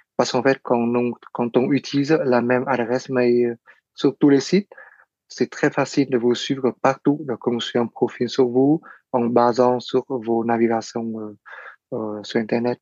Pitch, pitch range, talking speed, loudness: 125 Hz, 120-135 Hz, 160 wpm, -21 LUFS